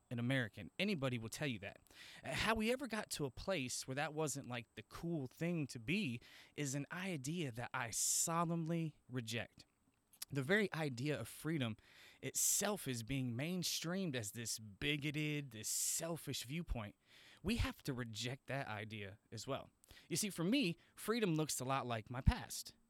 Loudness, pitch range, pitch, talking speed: -41 LUFS, 120-165 Hz, 135 Hz, 170 wpm